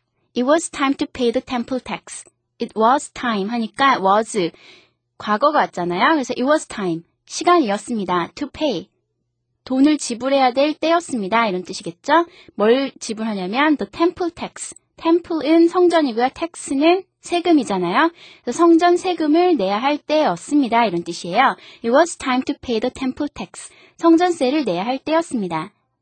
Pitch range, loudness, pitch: 215-320 Hz, -19 LUFS, 265 Hz